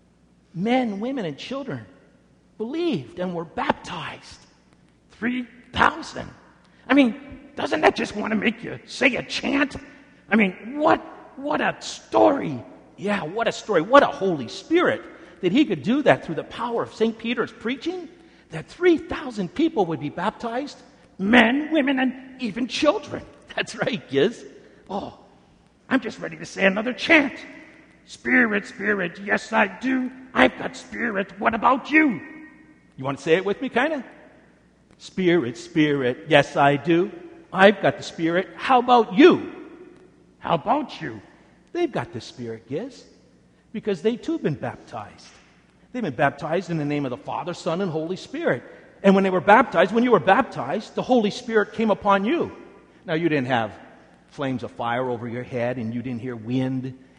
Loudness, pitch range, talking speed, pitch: -22 LUFS, 160-265 Hz, 165 wpm, 215 Hz